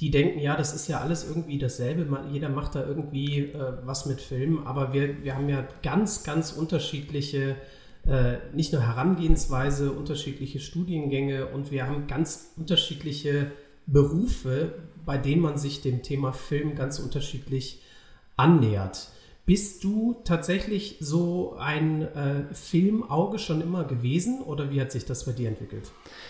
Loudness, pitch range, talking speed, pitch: -27 LUFS, 135-160 Hz, 150 wpm, 145 Hz